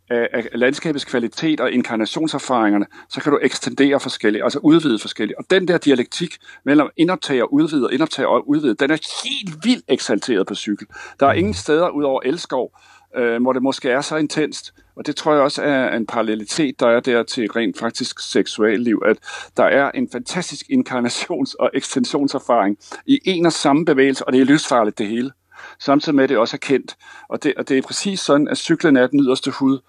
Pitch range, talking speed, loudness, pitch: 125-165 Hz, 205 wpm, -18 LUFS, 140 Hz